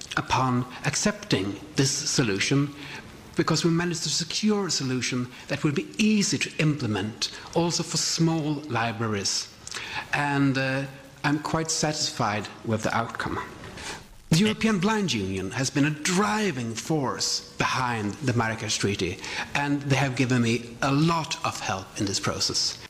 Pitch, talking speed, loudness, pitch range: 140 Hz, 140 wpm, -26 LUFS, 115-160 Hz